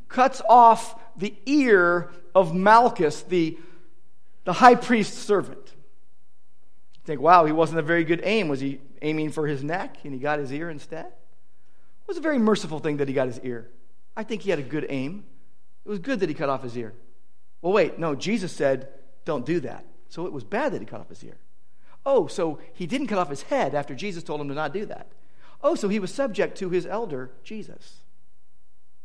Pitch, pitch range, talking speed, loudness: 165 Hz, 135-200 Hz, 210 wpm, -23 LUFS